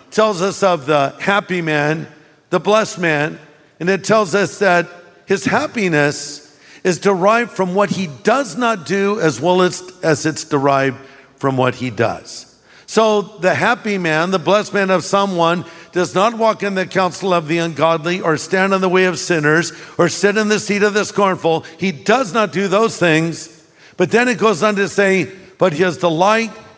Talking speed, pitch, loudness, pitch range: 190 wpm, 185 Hz, -16 LUFS, 160-200 Hz